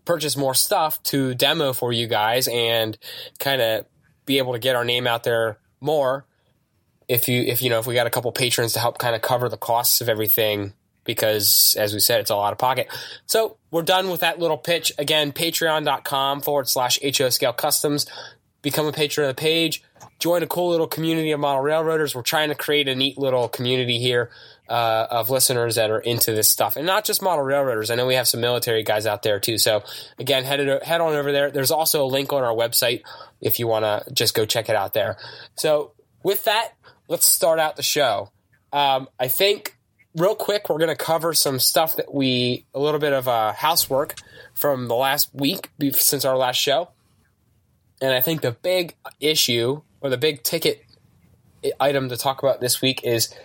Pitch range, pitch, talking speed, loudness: 120-155 Hz, 135 Hz, 210 wpm, -20 LUFS